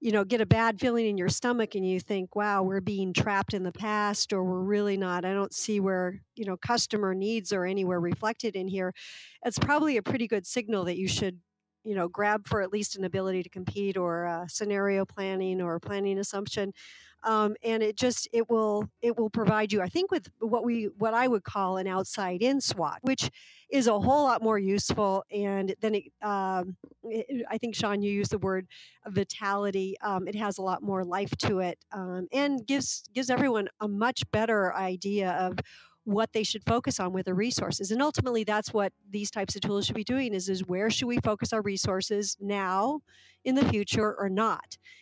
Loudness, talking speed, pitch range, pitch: -29 LUFS, 210 wpm, 190-225 Hz, 205 Hz